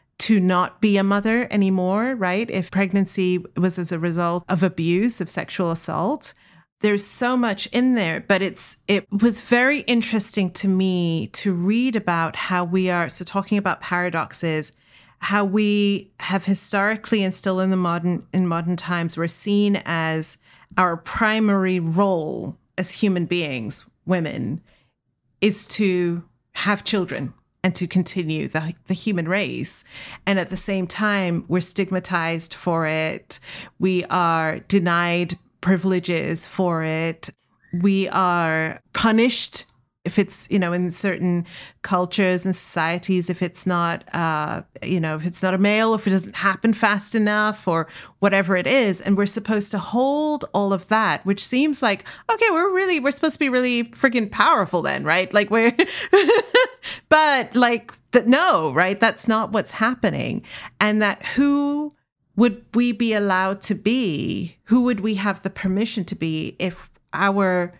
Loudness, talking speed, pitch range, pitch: -21 LUFS, 155 wpm, 175-220 Hz, 190 Hz